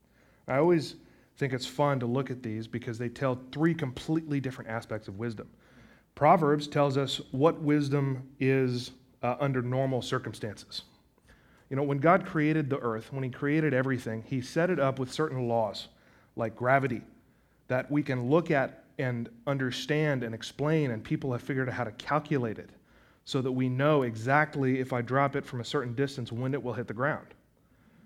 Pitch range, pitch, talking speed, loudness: 120-145 Hz, 130 Hz, 180 wpm, -30 LUFS